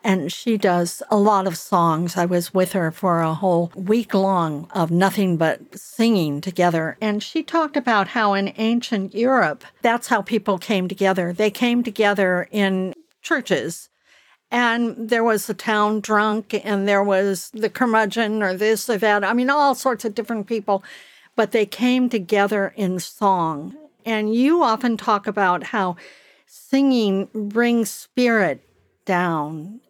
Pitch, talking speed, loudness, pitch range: 210 Hz, 155 wpm, -20 LUFS, 190-230 Hz